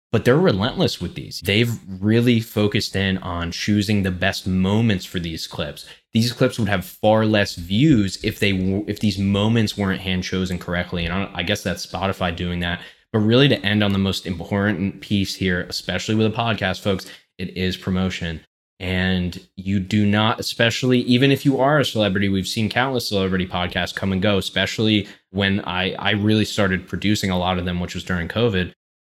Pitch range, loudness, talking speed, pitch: 90-105 Hz, -21 LUFS, 190 wpm, 95 Hz